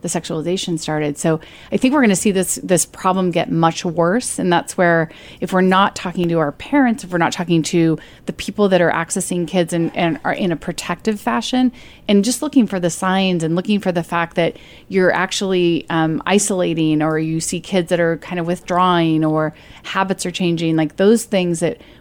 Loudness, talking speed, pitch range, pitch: -18 LUFS, 210 wpm, 165-190 Hz, 175 Hz